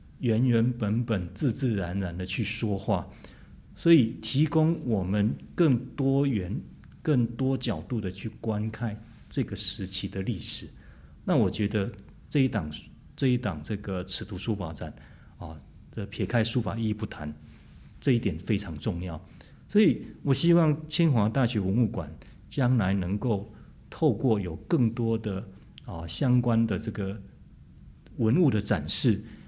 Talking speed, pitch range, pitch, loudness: 210 characters per minute, 95-120 Hz, 110 Hz, -28 LUFS